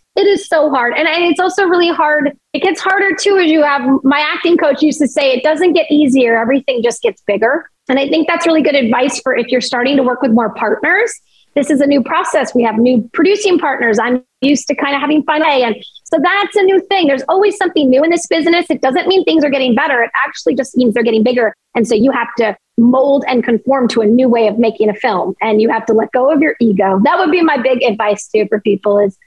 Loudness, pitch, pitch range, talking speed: -12 LUFS, 270 Hz, 235-320 Hz, 255 wpm